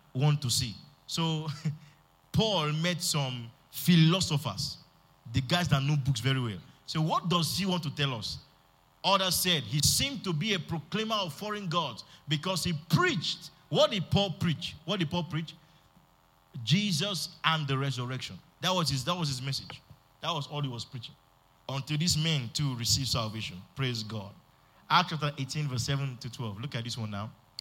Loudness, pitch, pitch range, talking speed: -30 LUFS, 150 Hz, 130-170 Hz, 180 wpm